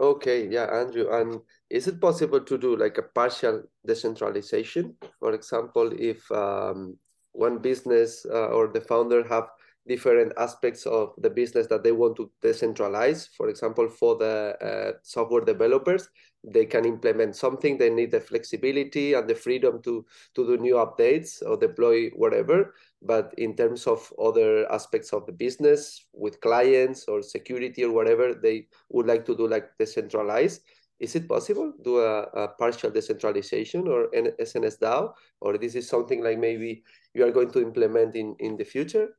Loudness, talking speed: -25 LUFS, 165 wpm